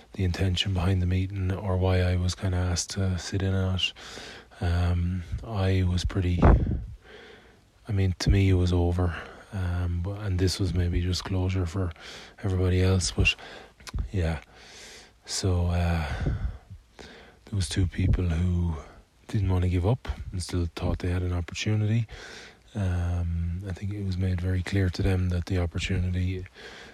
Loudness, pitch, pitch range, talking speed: -28 LUFS, 90 Hz, 90-95 Hz, 165 wpm